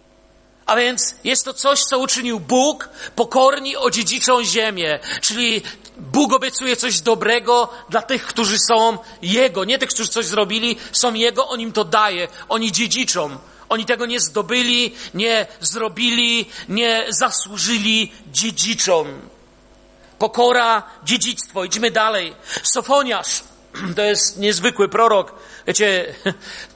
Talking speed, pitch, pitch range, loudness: 120 wpm, 230 Hz, 215-245 Hz, -17 LUFS